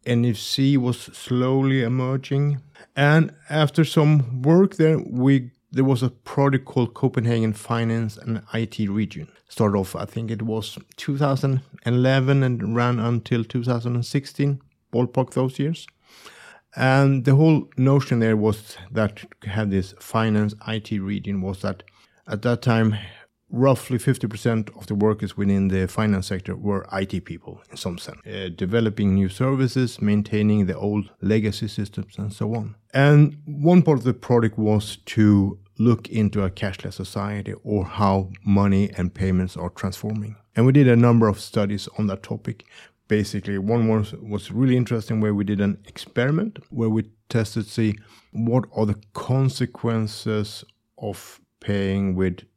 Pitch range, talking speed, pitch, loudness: 105-130 Hz, 150 wpm, 110 Hz, -22 LUFS